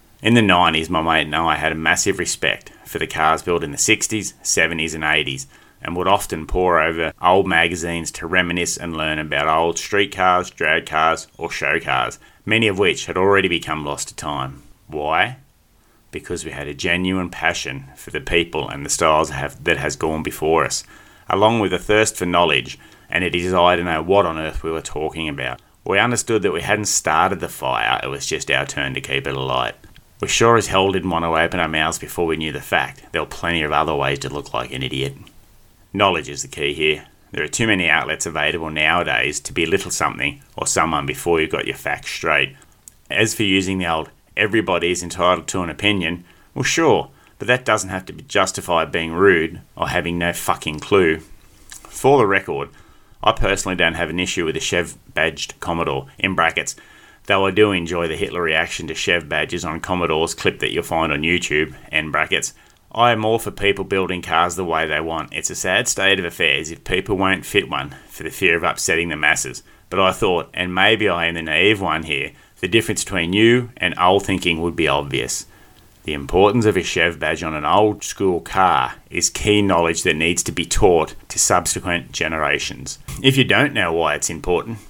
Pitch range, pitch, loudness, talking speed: 80-95 Hz, 85 Hz, -19 LUFS, 210 wpm